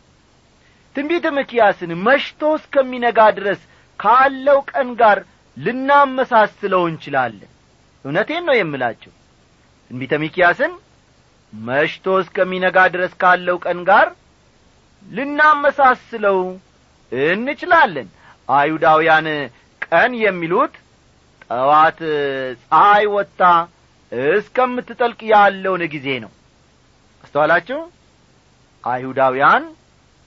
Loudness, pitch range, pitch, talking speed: -16 LUFS, 155-255 Hz, 190 Hz, 70 wpm